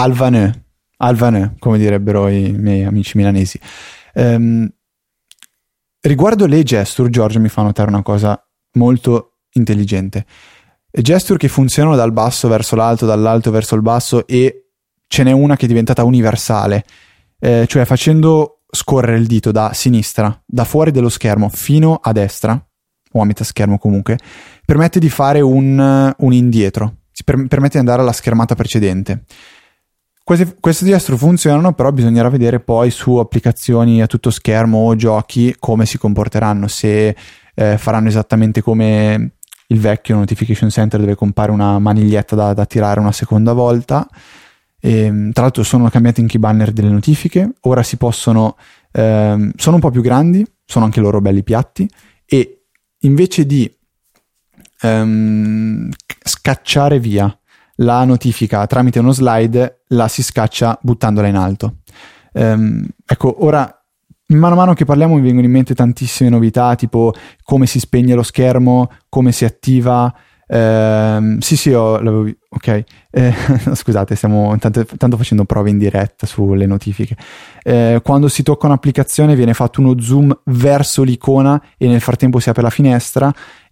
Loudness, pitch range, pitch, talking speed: -13 LUFS, 110-130 Hz, 115 Hz, 150 wpm